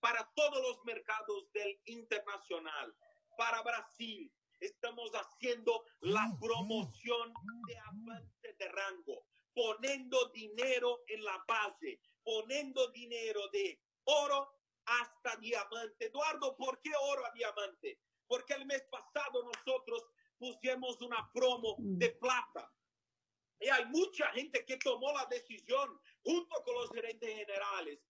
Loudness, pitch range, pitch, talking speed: -38 LUFS, 225-295 Hz, 250 Hz, 120 wpm